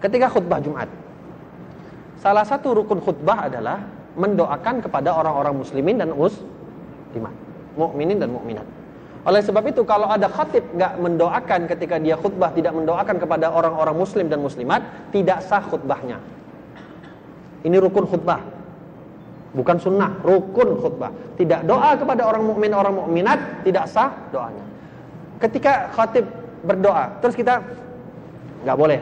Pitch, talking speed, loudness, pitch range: 180 Hz, 130 wpm, -20 LUFS, 165-210 Hz